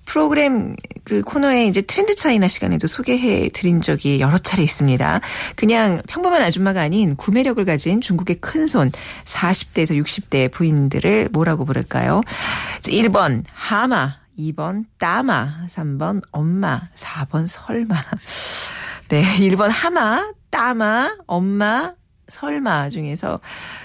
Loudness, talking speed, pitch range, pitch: -18 LUFS, 245 characters per minute, 160-235 Hz, 190 Hz